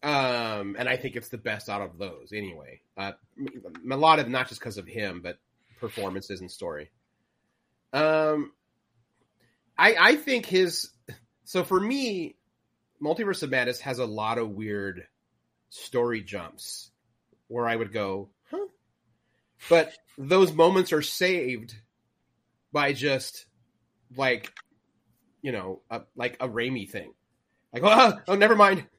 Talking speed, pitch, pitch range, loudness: 140 wpm, 120 Hz, 110-155 Hz, -25 LUFS